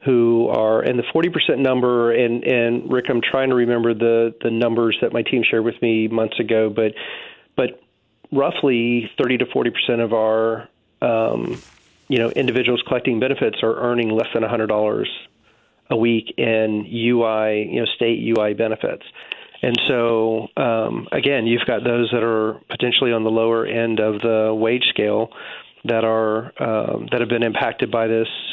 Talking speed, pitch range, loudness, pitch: 170 wpm, 110-120 Hz, -19 LUFS, 115 Hz